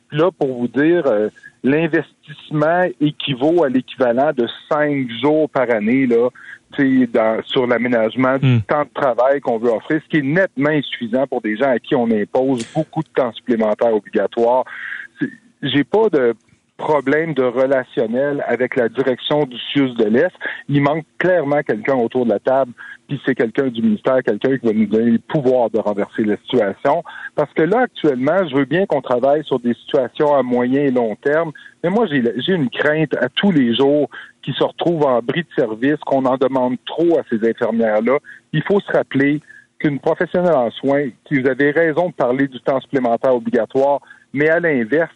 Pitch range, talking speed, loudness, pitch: 125-155 Hz, 190 wpm, -17 LUFS, 140 Hz